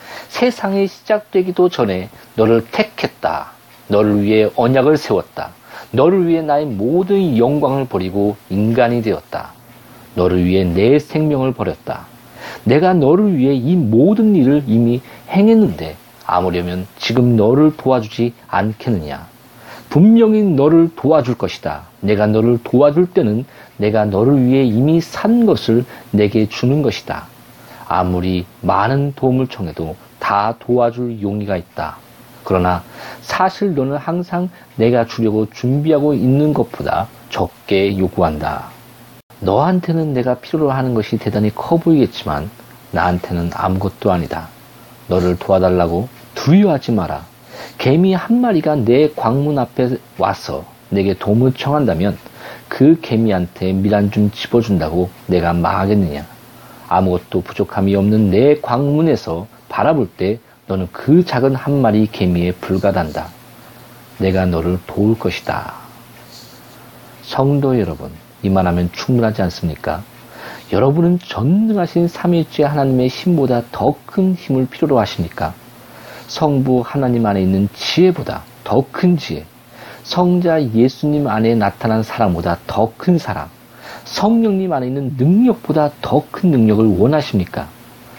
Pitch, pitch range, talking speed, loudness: 120 Hz, 100-145 Hz, 280 characters per minute, -15 LUFS